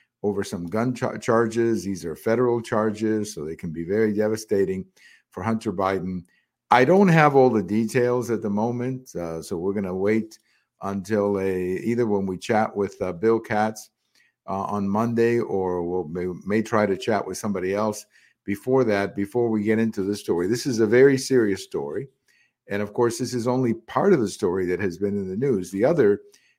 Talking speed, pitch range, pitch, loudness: 195 wpm, 100-115 Hz, 110 Hz, -23 LUFS